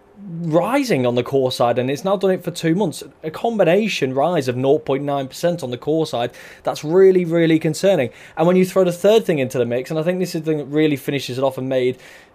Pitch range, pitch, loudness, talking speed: 135-180 Hz, 155 Hz, -19 LUFS, 245 wpm